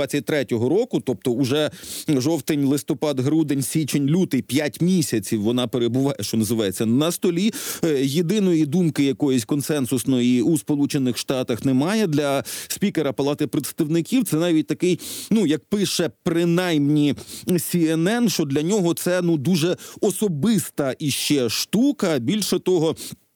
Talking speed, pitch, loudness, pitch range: 115 wpm, 155 Hz, -21 LUFS, 135-175 Hz